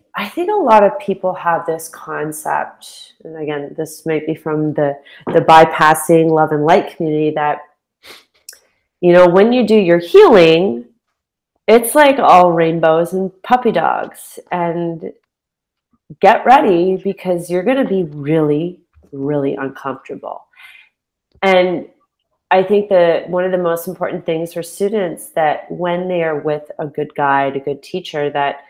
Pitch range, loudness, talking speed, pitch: 155-185 Hz, -14 LUFS, 150 wpm, 170 Hz